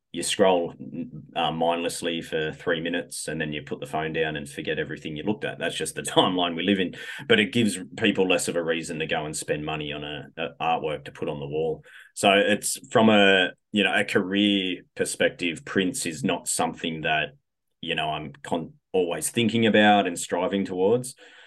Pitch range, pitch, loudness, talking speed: 80-105 Hz, 90 Hz, -25 LUFS, 205 wpm